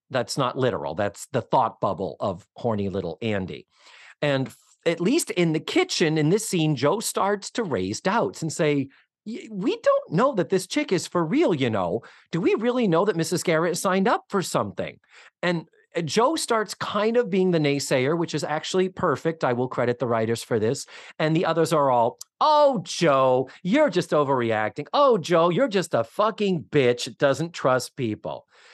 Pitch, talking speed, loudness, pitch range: 165 Hz, 190 wpm, -24 LUFS, 140-195 Hz